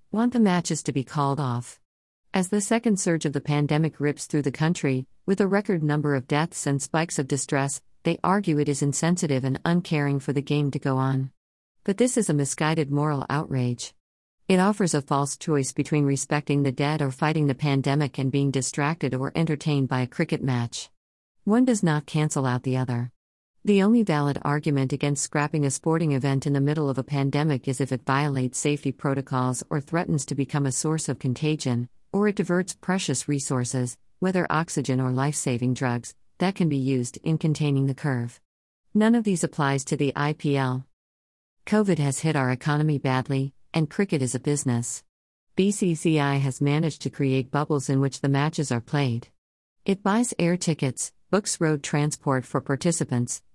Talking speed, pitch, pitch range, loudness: 185 wpm, 145 Hz, 130-160 Hz, -25 LUFS